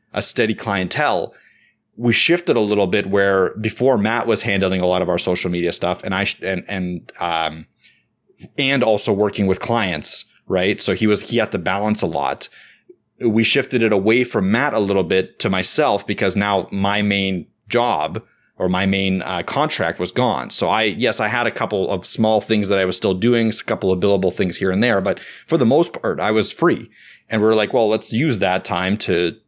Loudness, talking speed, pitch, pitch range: -18 LUFS, 215 wpm, 100 Hz, 95-110 Hz